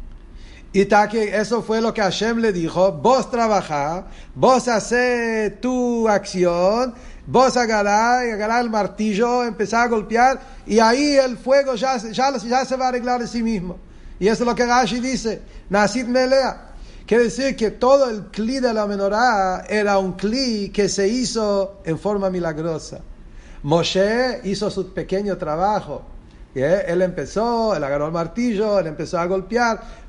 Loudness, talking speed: -19 LUFS, 160 wpm